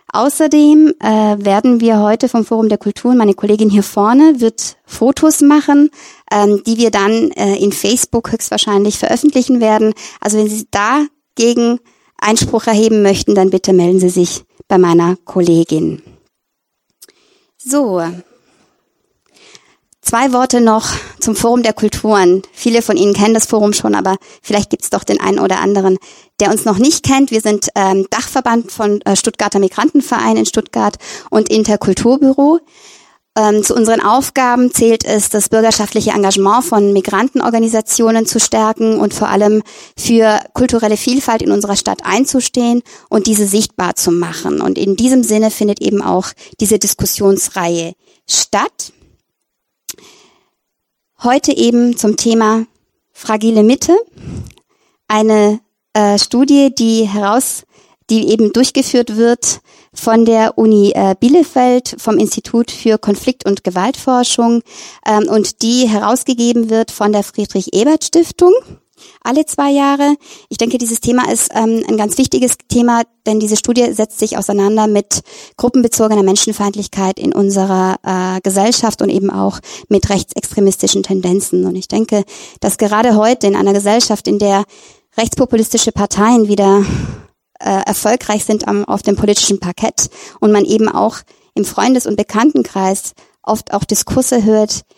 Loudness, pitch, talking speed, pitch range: -12 LUFS, 220 Hz, 140 wpm, 205-245 Hz